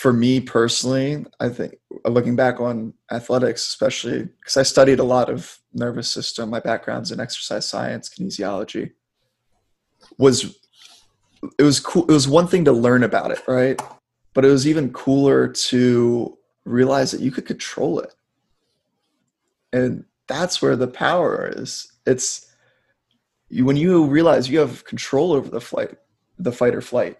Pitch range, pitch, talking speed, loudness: 120-140 Hz, 130 Hz, 150 wpm, -19 LUFS